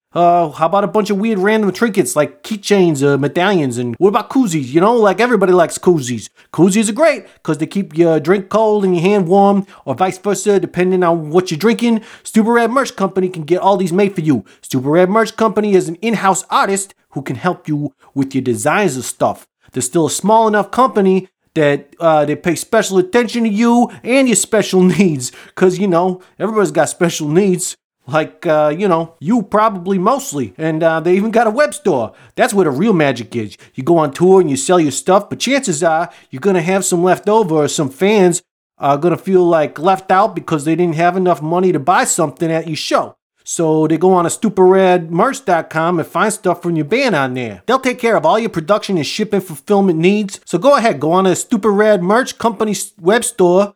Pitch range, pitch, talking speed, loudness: 160-210 Hz, 185 Hz, 220 wpm, -14 LUFS